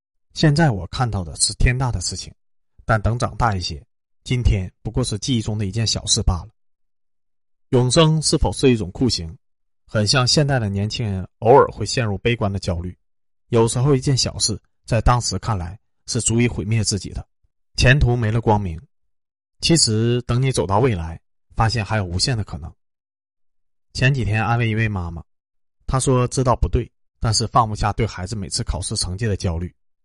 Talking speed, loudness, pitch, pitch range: 270 characters per minute, -20 LUFS, 110 Hz, 90-120 Hz